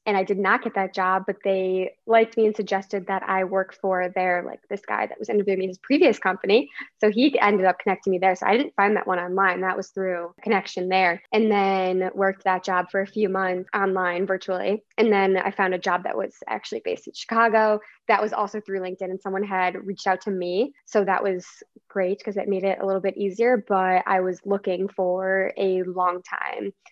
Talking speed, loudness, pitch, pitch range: 225 wpm, -23 LUFS, 195 Hz, 185-205 Hz